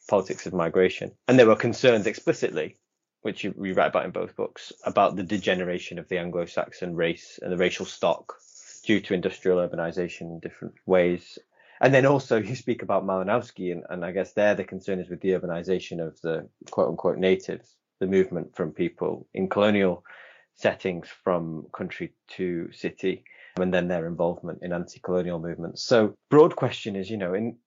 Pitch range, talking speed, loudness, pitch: 90-95 Hz, 180 wpm, -26 LUFS, 95 Hz